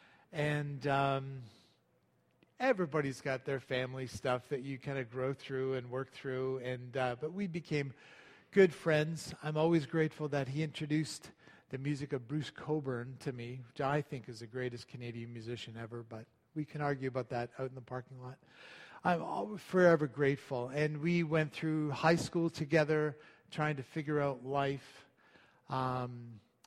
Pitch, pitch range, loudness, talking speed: 140 Hz, 130-155 Hz, -36 LUFS, 165 wpm